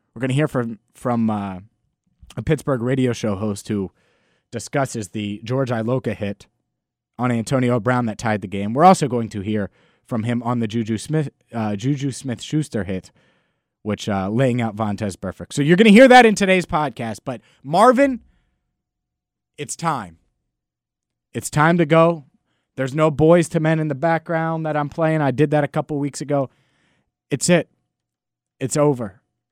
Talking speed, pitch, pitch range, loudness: 175 wpm, 125 Hz, 105-155 Hz, -19 LUFS